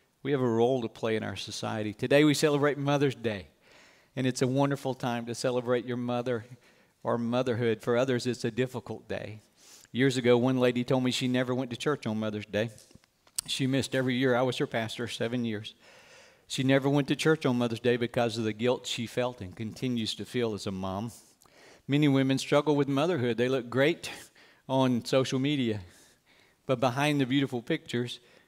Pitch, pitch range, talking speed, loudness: 125 Hz, 115-135 Hz, 195 wpm, -29 LUFS